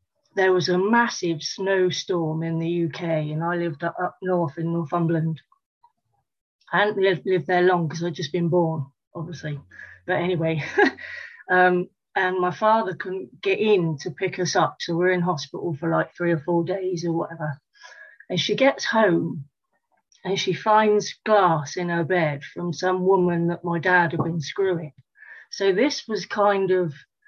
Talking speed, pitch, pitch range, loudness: 165 wpm, 180 Hz, 165-195 Hz, -23 LUFS